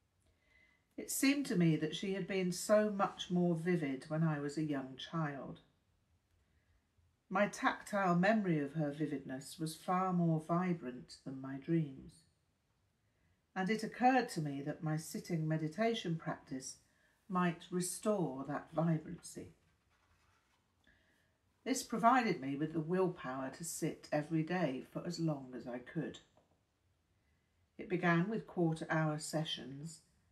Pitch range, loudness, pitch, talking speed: 125-180 Hz, -37 LUFS, 155 Hz, 135 wpm